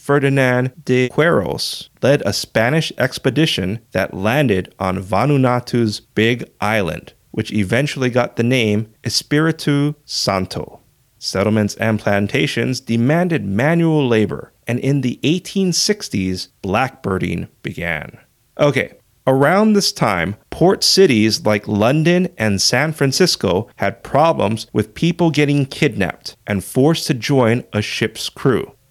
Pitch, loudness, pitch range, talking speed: 125 Hz, -17 LUFS, 110-150 Hz, 115 wpm